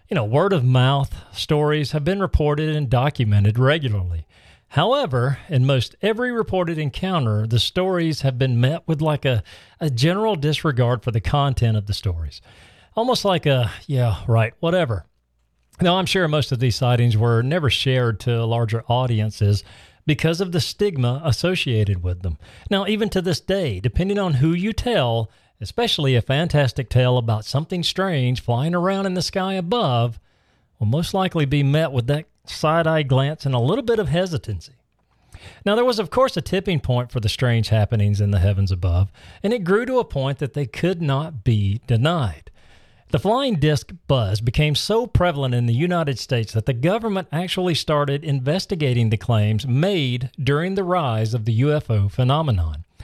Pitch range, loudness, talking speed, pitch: 115-170 Hz, -21 LUFS, 175 wpm, 135 Hz